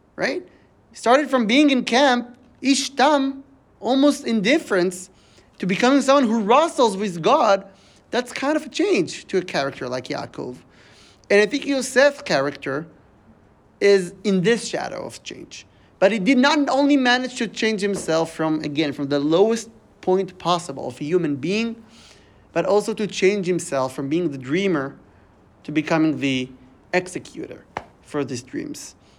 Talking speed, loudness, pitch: 150 wpm, -20 LUFS, 190 Hz